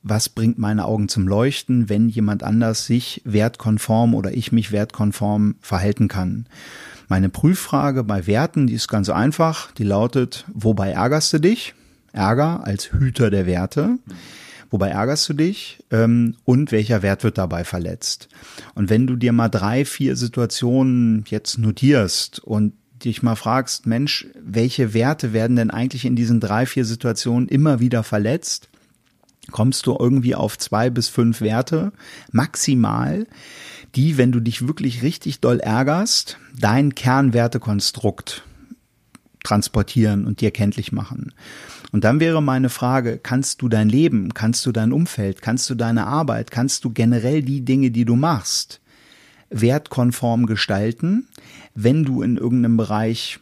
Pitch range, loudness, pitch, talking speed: 110-130 Hz, -19 LUFS, 120 Hz, 145 wpm